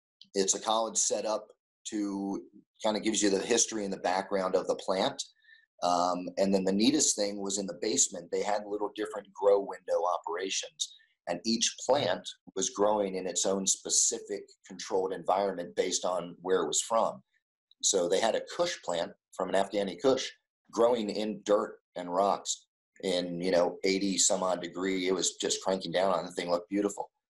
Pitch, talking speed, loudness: 105 Hz, 185 wpm, -30 LUFS